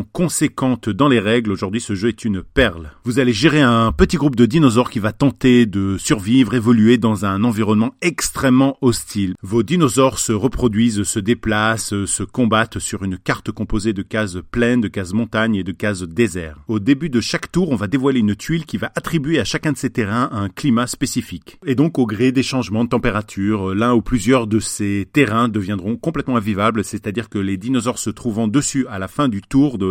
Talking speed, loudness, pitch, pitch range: 210 wpm, -18 LUFS, 115 Hz, 105-130 Hz